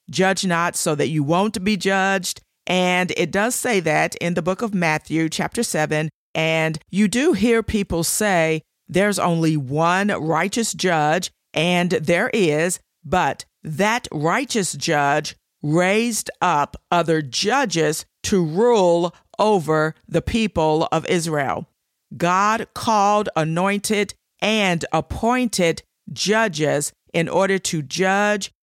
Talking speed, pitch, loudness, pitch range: 125 wpm, 180 Hz, -20 LUFS, 160-205 Hz